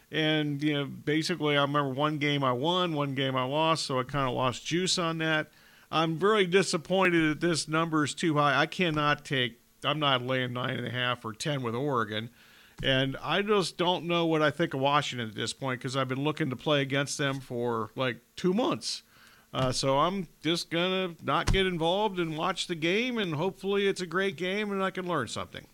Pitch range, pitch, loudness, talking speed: 135-175 Hz, 150 Hz, -28 LUFS, 215 wpm